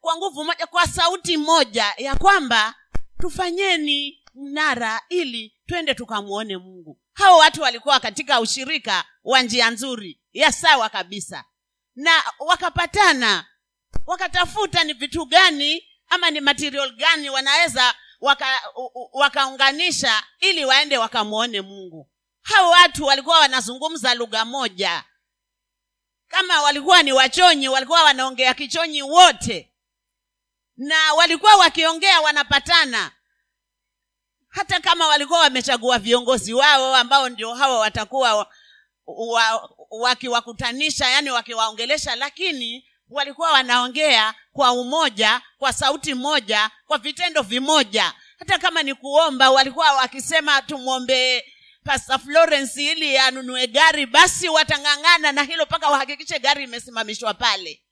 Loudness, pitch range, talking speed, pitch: -17 LUFS, 250-325 Hz, 105 wpm, 285 Hz